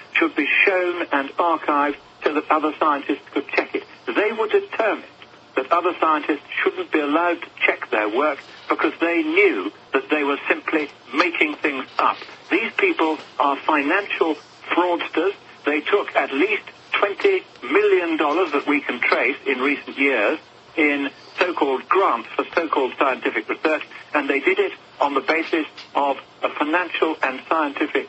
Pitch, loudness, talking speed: 315 Hz, -21 LUFS, 155 wpm